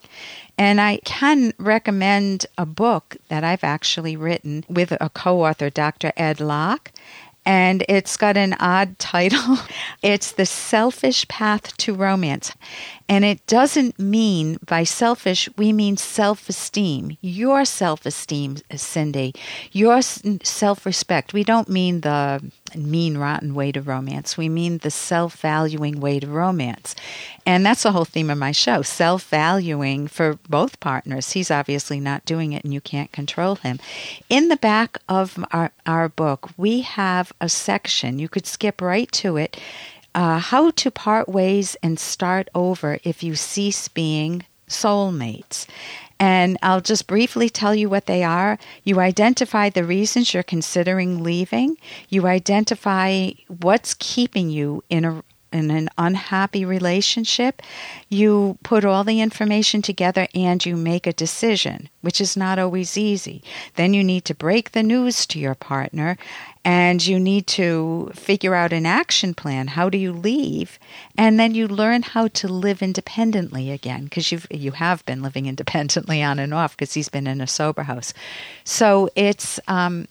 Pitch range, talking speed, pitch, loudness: 155-205 Hz, 155 wpm, 180 Hz, -20 LUFS